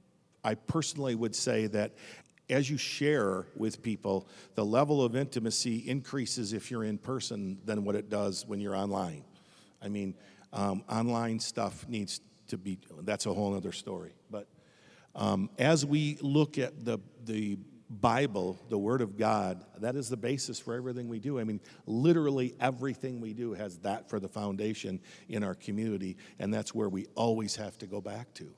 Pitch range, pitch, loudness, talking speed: 100-130 Hz, 115 Hz, -33 LUFS, 175 wpm